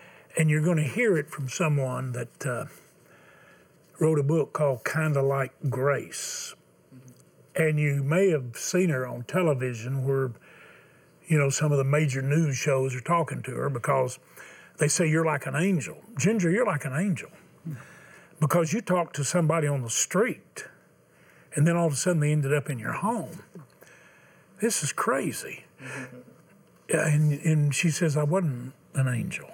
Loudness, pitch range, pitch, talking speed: -26 LUFS, 135-165 Hz, 150 Hz, 165 wpm